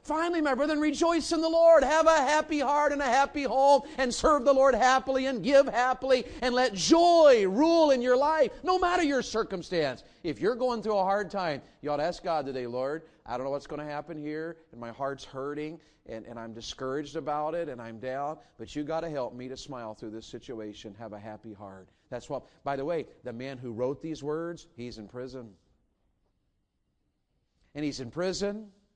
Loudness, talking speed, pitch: -27 LUFS, 210 wpm, 165 Hz